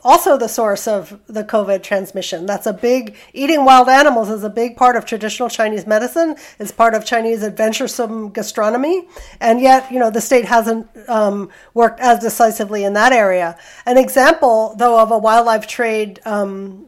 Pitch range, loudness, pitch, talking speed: 215-245 Hz, -15 LUFS, 225 Hz, 175 wpm